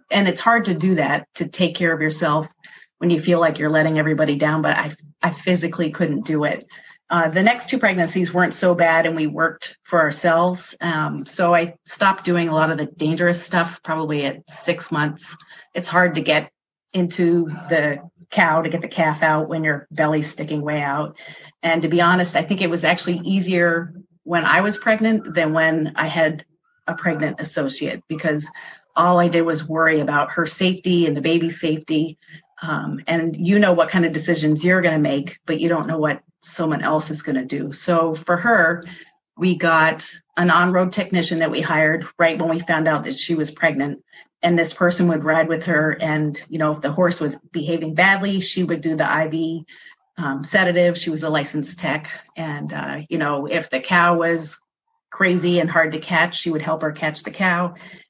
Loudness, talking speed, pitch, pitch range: -19 LUFS, 205 wpm, 165 Hz, 155-175 Hz